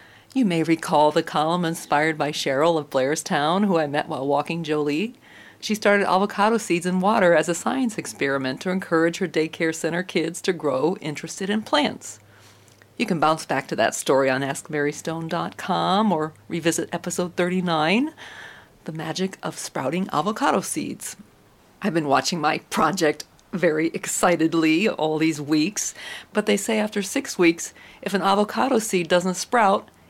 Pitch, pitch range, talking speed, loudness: 170 Hz, 155-195 Hz, 155 wpm, -22 LUFS